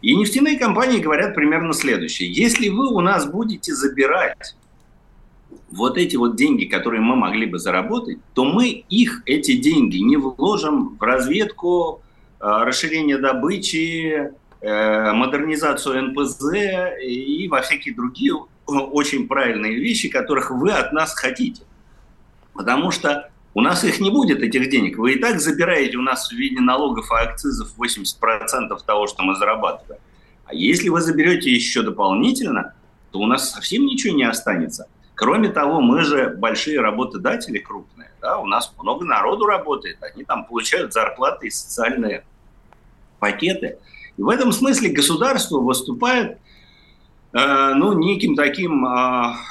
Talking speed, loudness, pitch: 140 wpm, -19 LUFS, 195 Hz